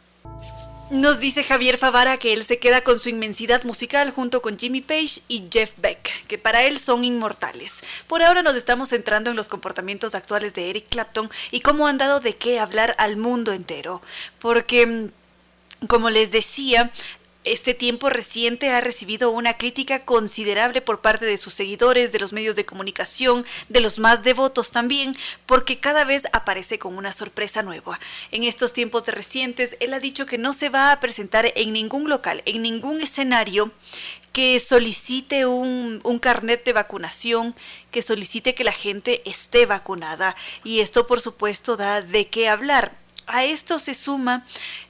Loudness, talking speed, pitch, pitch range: -20 LUFS, 170 wpm, 235 Hz, 215-255 Hz